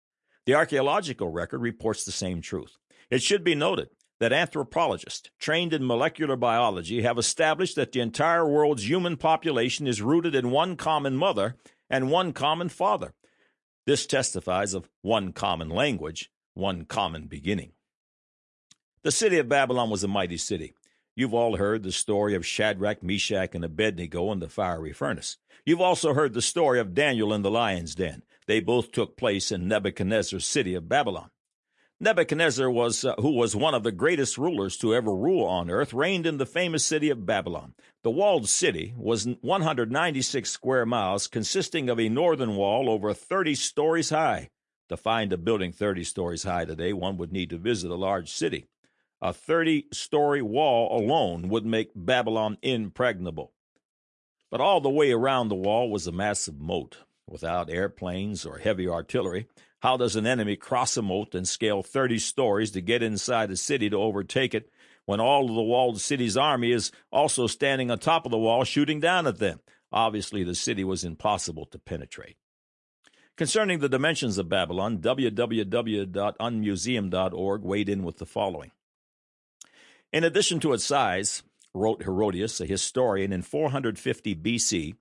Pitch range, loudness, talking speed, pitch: 95-135 Hz, -26 LUFS, 165 wpm, 110 Hz